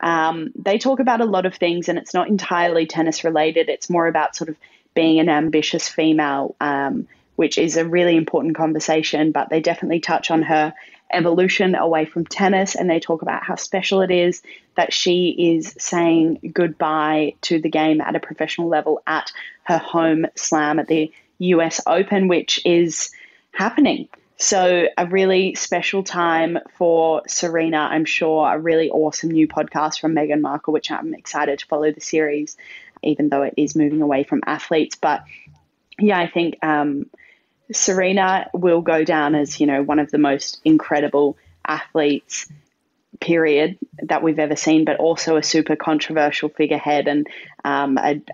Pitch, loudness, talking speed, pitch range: 160 Hz, -19 LUFS, 170 wpm, 150-175 Hz